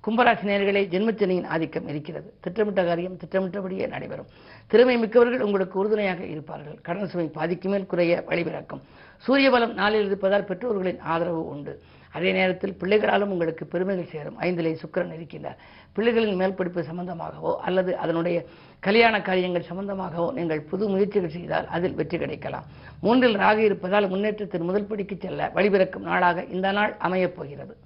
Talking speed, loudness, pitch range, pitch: 135 wpm, -24 LUFS, 170-205 Hz, 185 Hz